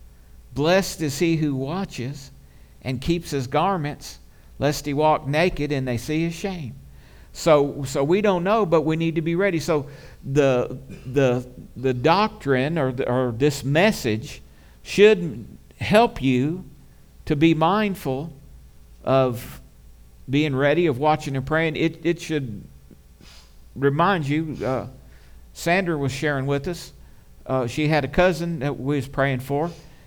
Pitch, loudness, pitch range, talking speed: 145 Hz, -22 LUFS, 125-165 Hz, 145 wpm